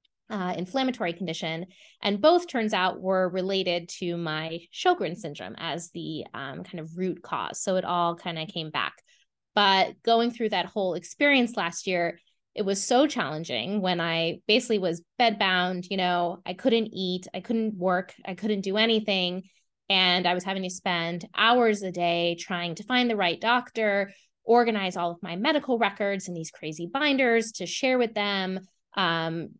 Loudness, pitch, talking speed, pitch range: -26 LUFS, 185 Hz, 175 wpm, 175-220 Hz